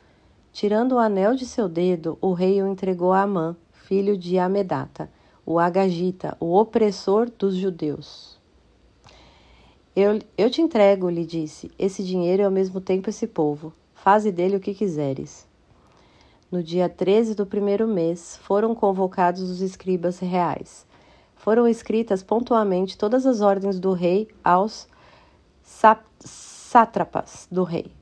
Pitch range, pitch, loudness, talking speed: 180-210 Hz, 195 Hz, -22 LUFS, 135 wpm